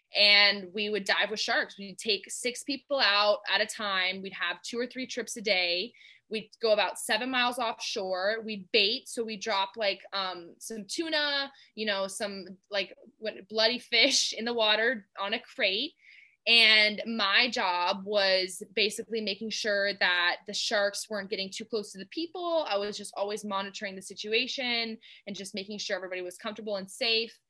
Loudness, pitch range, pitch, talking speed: -28 LUFS, 200-230 Hz, 210 Hz, 180 wpm